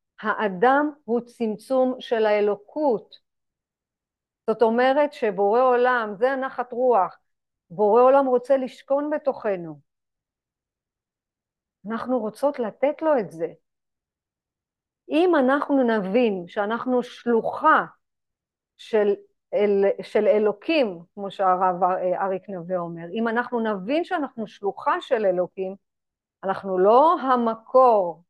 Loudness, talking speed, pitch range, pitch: -22 LUFS, 100 wpm, 200-260 Hz, 230 Hz